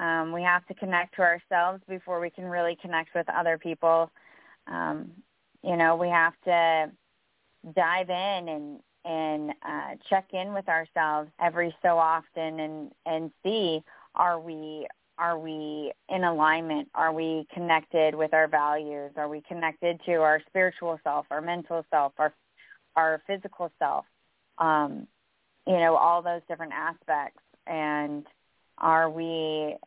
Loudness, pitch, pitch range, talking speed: -27 LUFS, 165 Hz, 155-175 Hz, 145 wpm